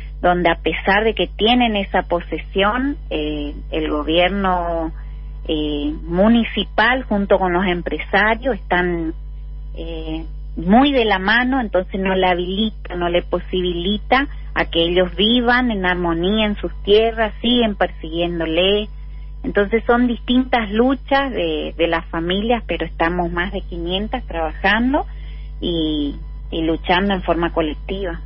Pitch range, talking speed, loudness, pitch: 165-215 Hz, 130 wpm, -18 LUFS, 180 Hz